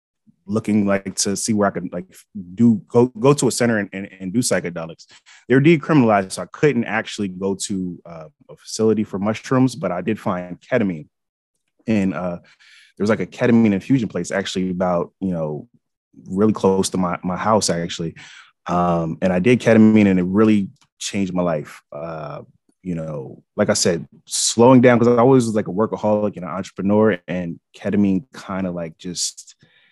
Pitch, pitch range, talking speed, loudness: 100 Hz, 90-115 Hz, 185 wpm, -19 LUFS